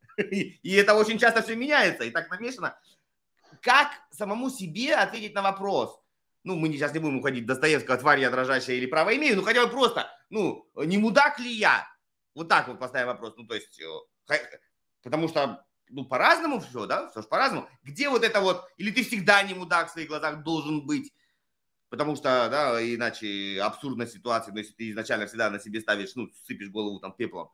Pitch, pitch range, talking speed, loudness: 165 Hz, 125-215 Hz, 195 wpm, -26 LUFS